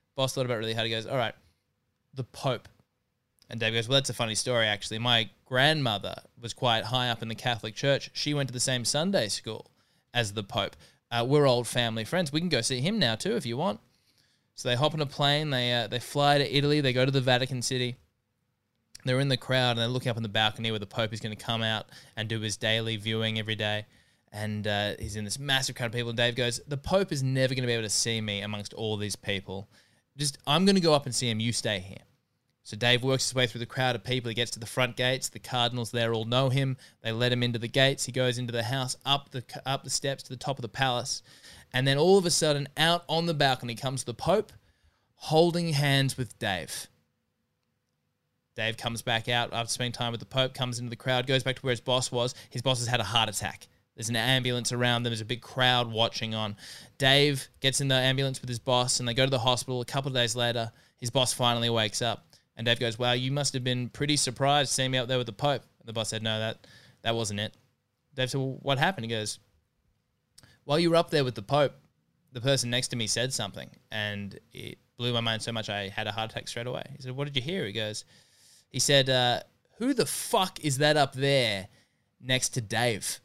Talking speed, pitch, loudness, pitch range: 250 wpm, 125 Hz, -28 LUFS, 115-135 Hz